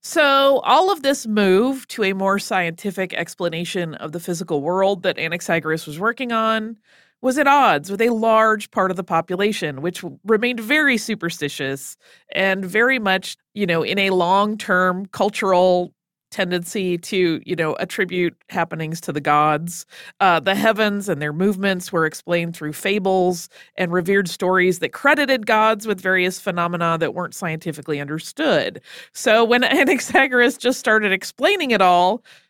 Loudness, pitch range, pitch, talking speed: -19 LUFS, 170-220 Hz, 190 Hz, 155 wpm